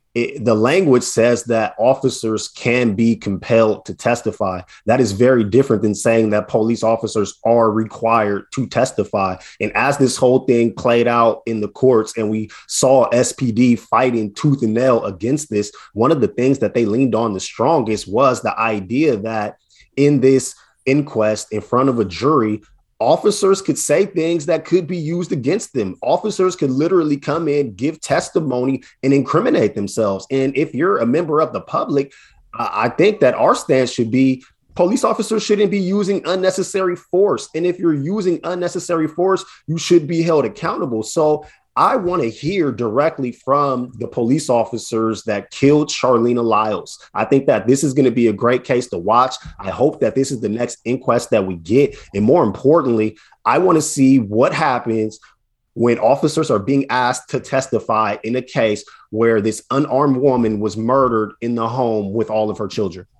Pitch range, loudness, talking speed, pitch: 110-145 Hz, -17 LUFS, 180 wpm, 125 Hz